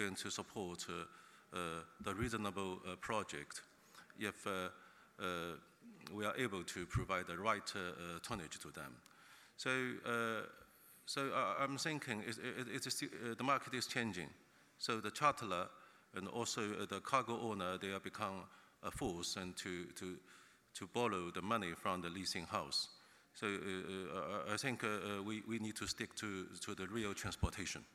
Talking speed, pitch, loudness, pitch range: 170 wpm, 105 Hz, -43 LUFS, 95-115 Hz